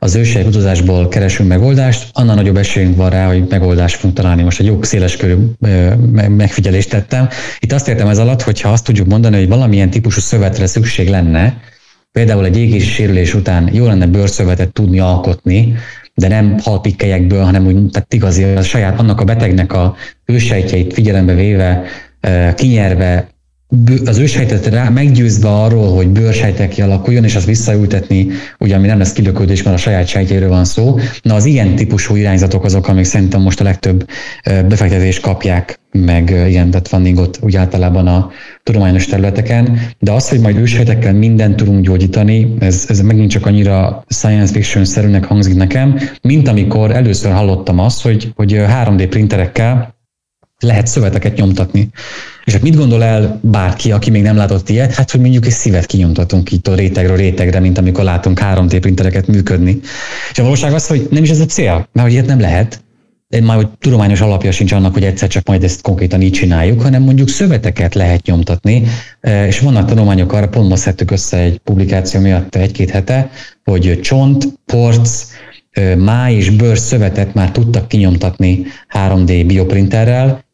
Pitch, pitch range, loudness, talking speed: 100 Hz, 95-115 Hz, -11 LUFS, 165 wpm